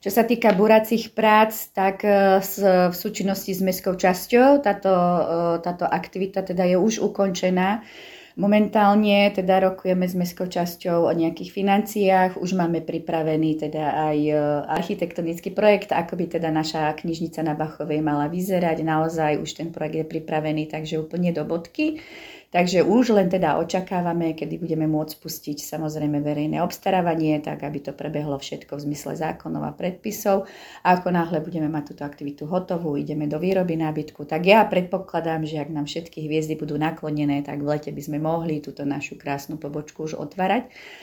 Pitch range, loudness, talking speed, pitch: 155-190 Hz, -23 LUFS, 160 wpm, 170 Hz